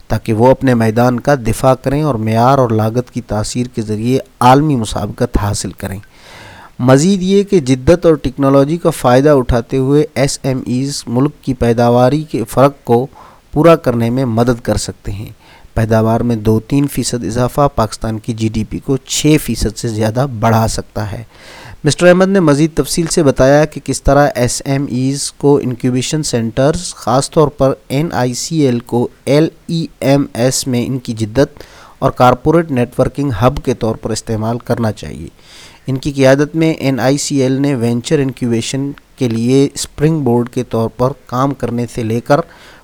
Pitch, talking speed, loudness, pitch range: 130 Hz, 180 wpm, -13 LUFS, 115-140 Hz